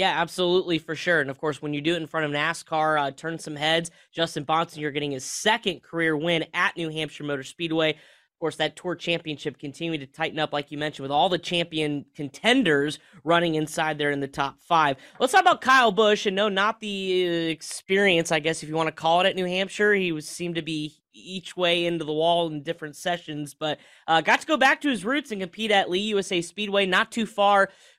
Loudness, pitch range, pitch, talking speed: -24 LUFS, 155-190 Hz, 165 Hz, 230 wpm